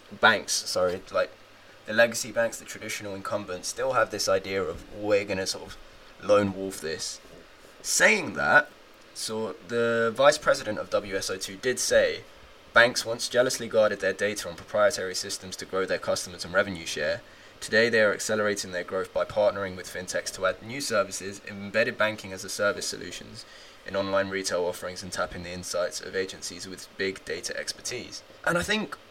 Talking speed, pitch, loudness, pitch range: 175 wpm, 100 Hz, -27 LUFS, 95-115 Hz